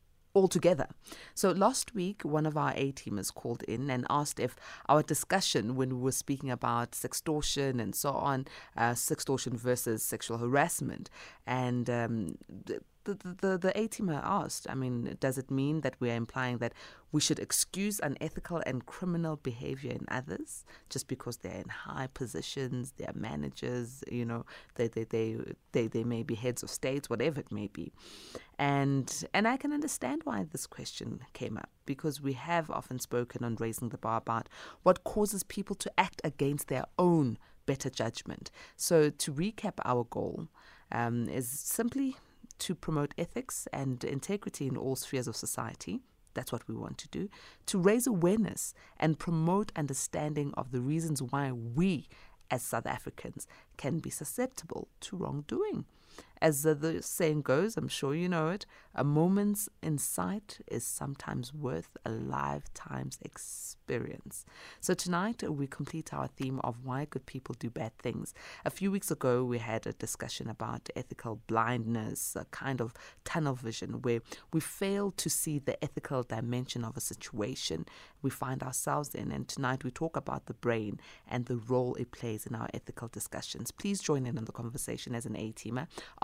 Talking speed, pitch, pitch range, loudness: 170 wpm, 135 Hz, 120-165 Hz, -34 LUFS